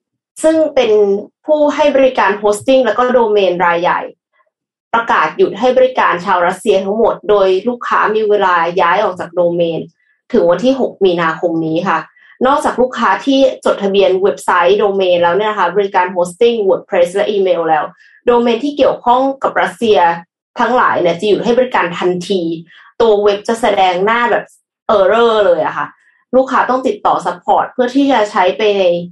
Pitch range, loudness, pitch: 180-245 Hz, -13 LUFS, 205 Hz